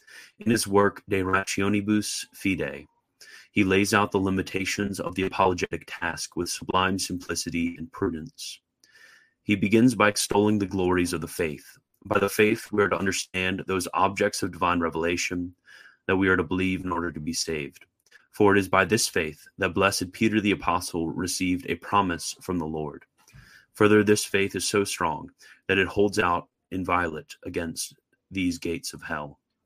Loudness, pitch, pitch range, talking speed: -25 LUFS, 95 Hz, 90-100 Hz, 170 wpm